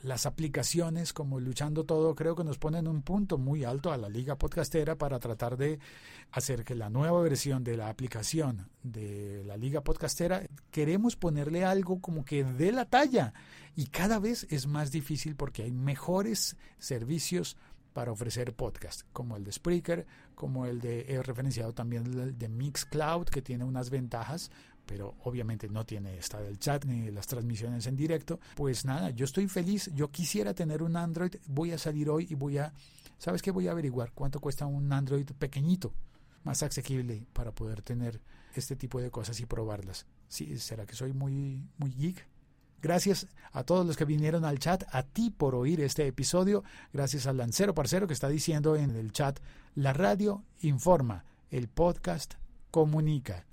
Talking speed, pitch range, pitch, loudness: 175 wpm, 125-160 Hz, 140 Hz, -33 LUFS